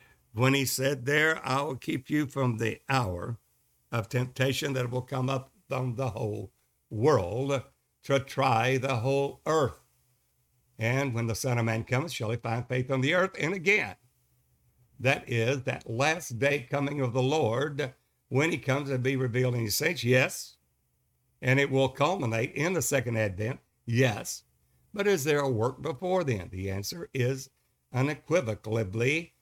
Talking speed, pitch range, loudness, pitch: 165 wpm, 115-140 Hz, -29 LUFS, 130 Hz